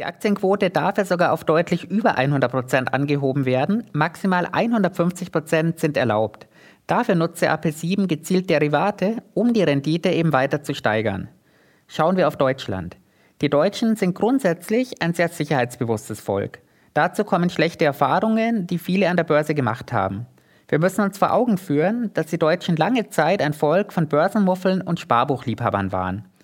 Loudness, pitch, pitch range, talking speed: -21 LUFS, 165 Hz, 140-190 Hz, 155 wpm